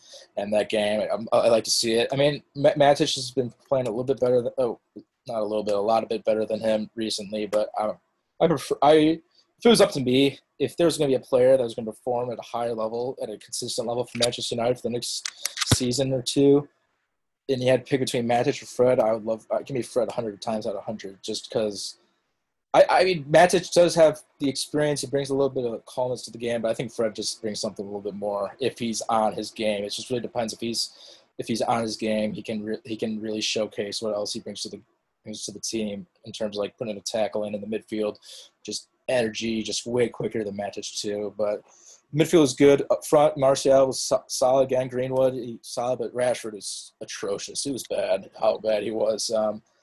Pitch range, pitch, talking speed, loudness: 110-135 Hz, 115 Hz, 245 wpm, -25 LUFS